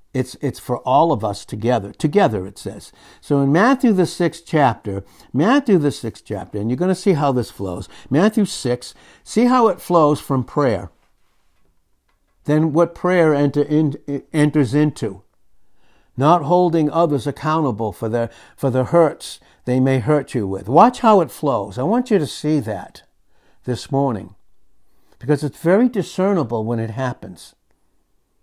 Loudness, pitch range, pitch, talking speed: -18 LUFS, 110-170 Hz, 140 Hz, 160 wpm